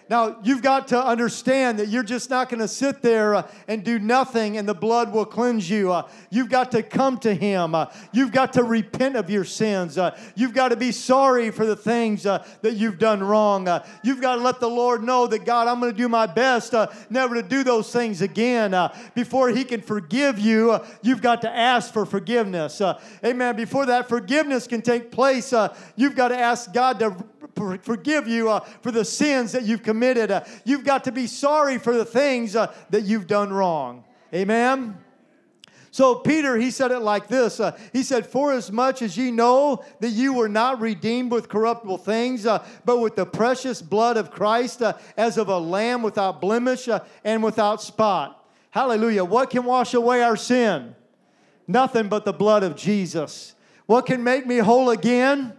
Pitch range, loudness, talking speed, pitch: 215-250 Hz, -21 LUFS, 205 wpm, 230 Hz